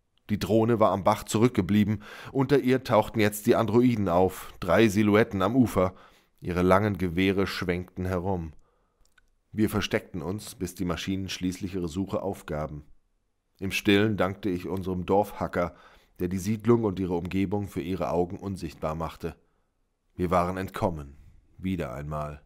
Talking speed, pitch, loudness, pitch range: 145 wpm, 95 Hz, -27 LUFS, 90-105 Hz